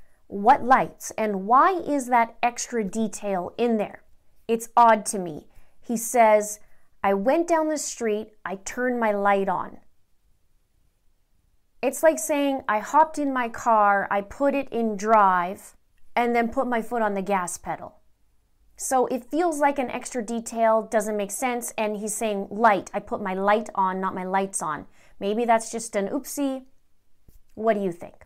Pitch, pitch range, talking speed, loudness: 225 Hz, 200-245 Hz, 170 wpm, -24 LUFS